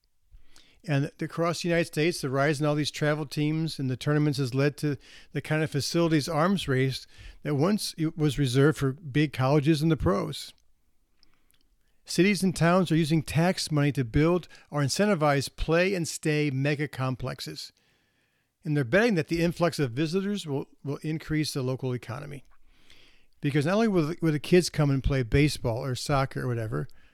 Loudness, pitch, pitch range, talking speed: -27 LUFS, 150 Hz, 135-165 Hz, 175 wpm